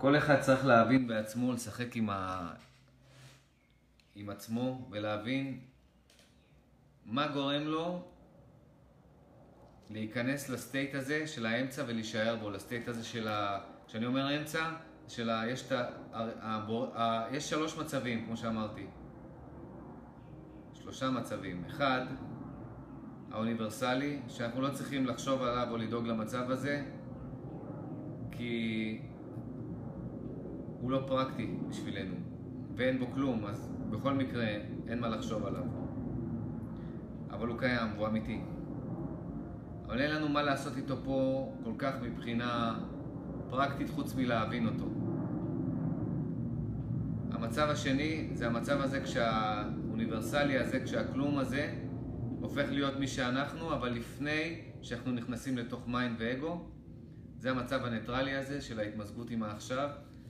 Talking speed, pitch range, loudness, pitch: 115 wpm, 115-135 Hz, -35 LUFS, 125 Hz